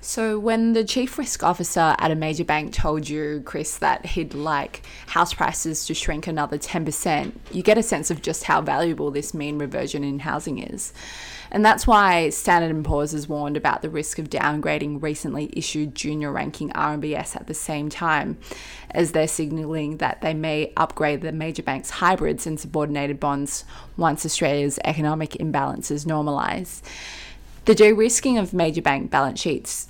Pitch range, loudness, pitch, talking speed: 150-170 Hz, -23 LUFS, 155 Hz, 165 wpm